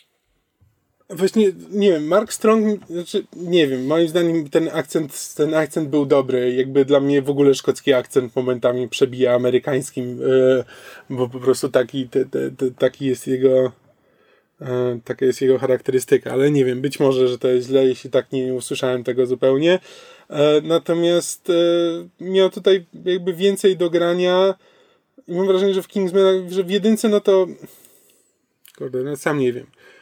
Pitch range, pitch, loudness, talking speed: 130-185 Hz, 150 Hz, -19 LUFS, 160 wpm